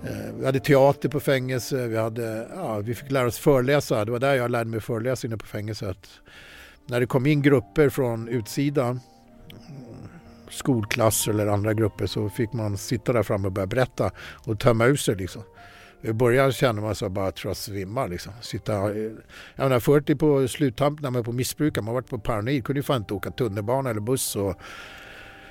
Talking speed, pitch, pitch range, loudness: 185 wpm, 120 Hz, 105-135 Hz, -24 LUFS